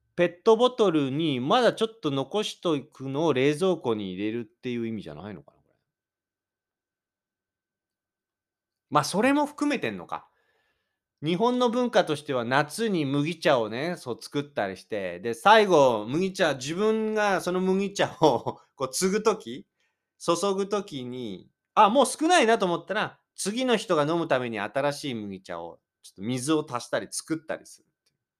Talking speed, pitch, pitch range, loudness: 290 characters per minute, 170 Hz, 130-210 Hz, -25 LUFS